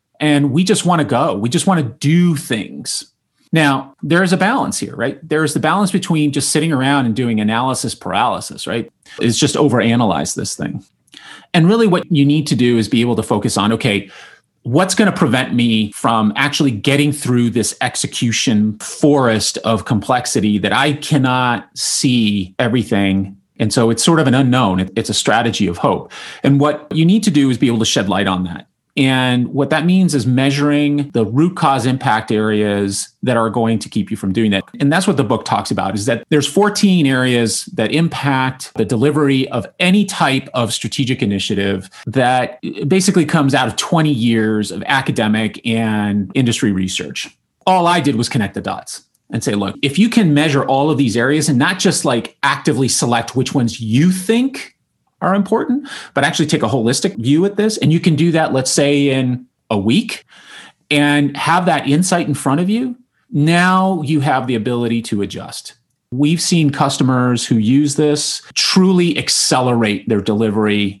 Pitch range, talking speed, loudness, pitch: 115-155 Hz, 190 wpm, -15 LUFS, 135 Hz